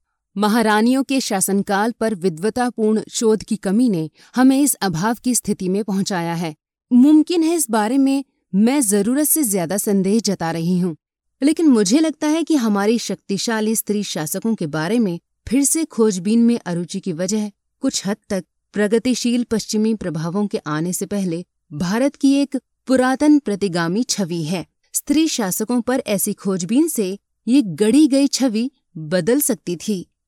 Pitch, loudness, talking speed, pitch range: 220 Hz, -18 LUFS, 155 wpm, 195-255 Hz